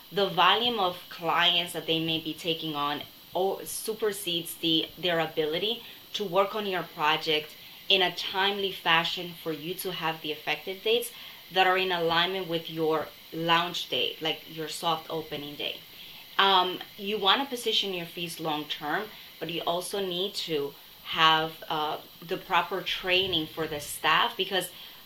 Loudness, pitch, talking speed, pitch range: -27 LUFS, 170 Hz, 160 wpm, 160-190 Hz